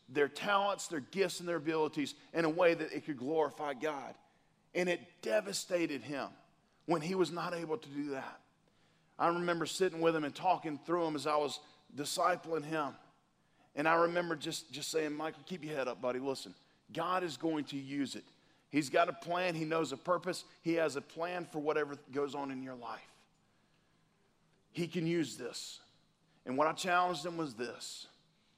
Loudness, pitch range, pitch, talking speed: -36 LUFS, 145-175 Hz, 160 Hz, 190 wpm